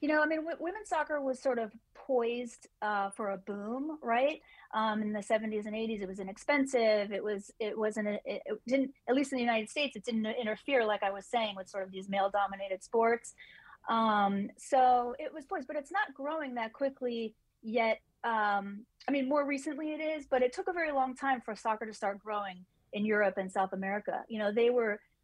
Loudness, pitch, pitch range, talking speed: -33 LUFS, 230 Hz, 210-270 Hz, 215 wpm